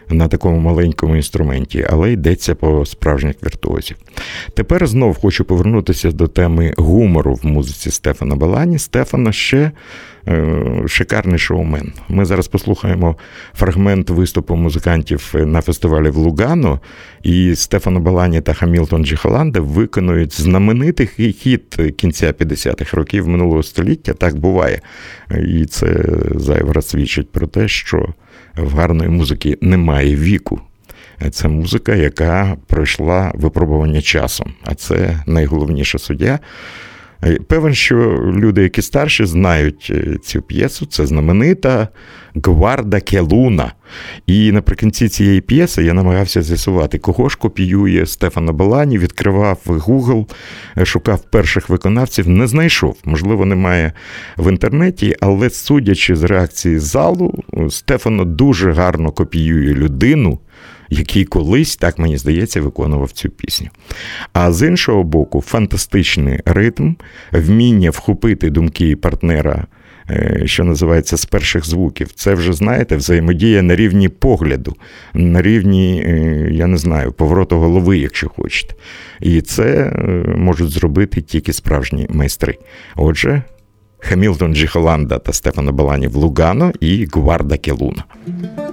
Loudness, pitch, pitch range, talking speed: -14 LUFS, 90 Hz, 80-100 Hz, 120 wpm